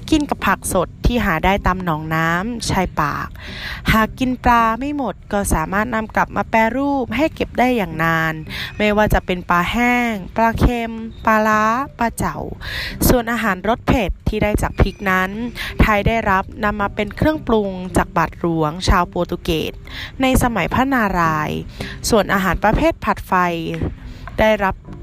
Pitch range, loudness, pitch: 180-235 Hz, -18 LUFS, 210 Hz